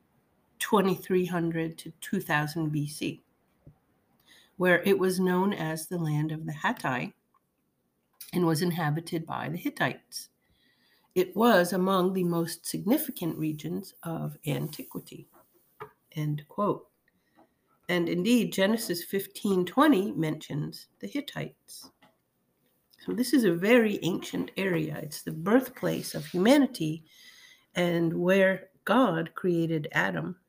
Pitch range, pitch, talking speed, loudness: 160-195 Hz, 180 Hz, 110 wpm, -28 LUFS